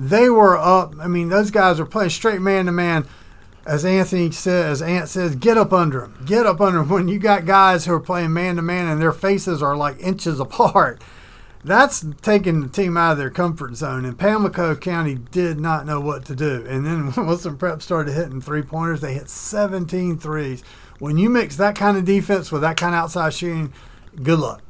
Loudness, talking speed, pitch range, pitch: -19 LUFS, 205 wpm, 150-185 Hz, 170 Hz